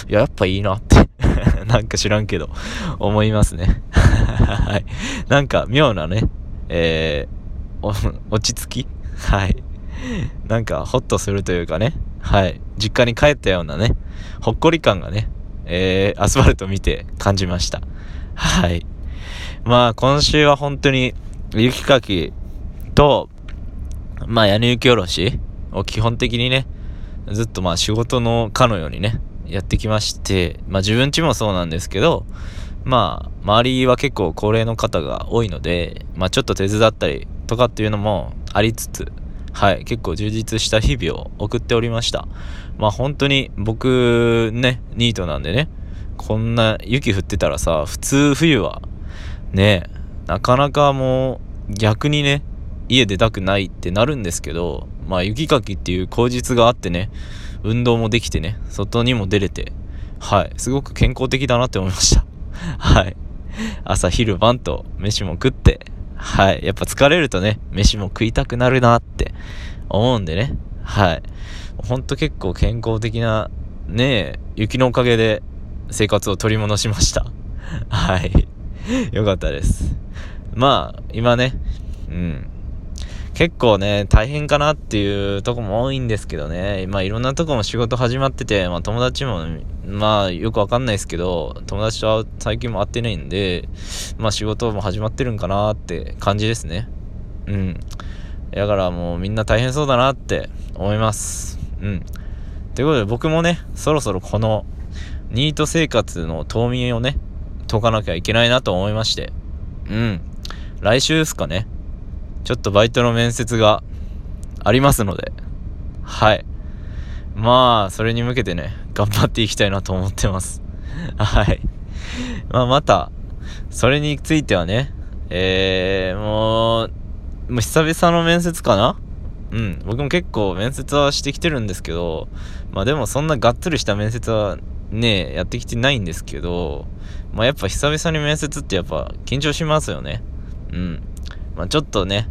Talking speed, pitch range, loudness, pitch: 295 characters per minute, 90-120 Hz, -18 LUFS, 105 Hz